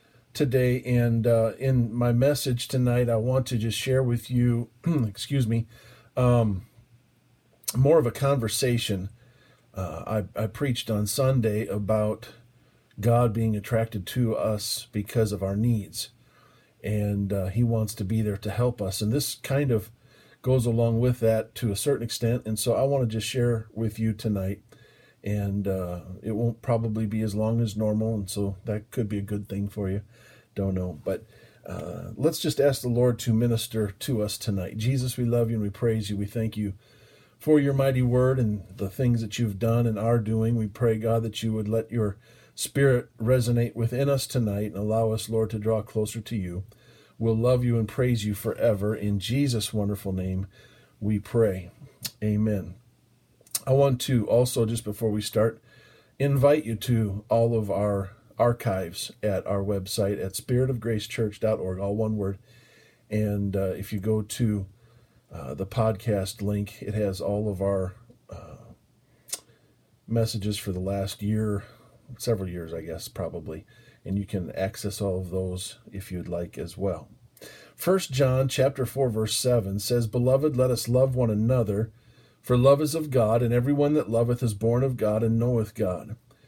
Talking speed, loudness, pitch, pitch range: 175 wpm, -26 LUFS, 115 Hz, 105-120 Hz